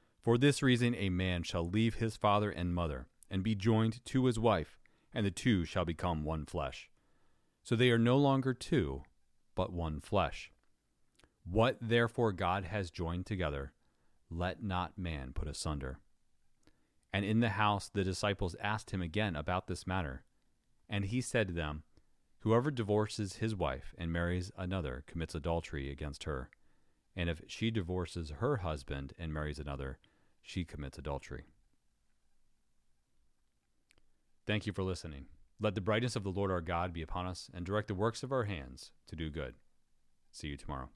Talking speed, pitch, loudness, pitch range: 165 wpm, 90 Hz, -36 LUFS, 80-110 Hz